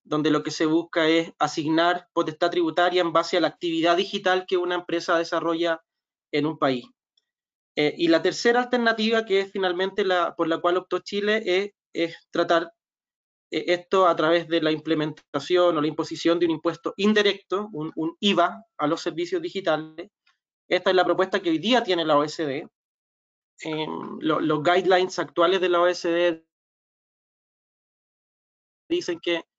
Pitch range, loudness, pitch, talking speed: 165-185 Hz, -24 LUFS, 175 Hz, 160 wpm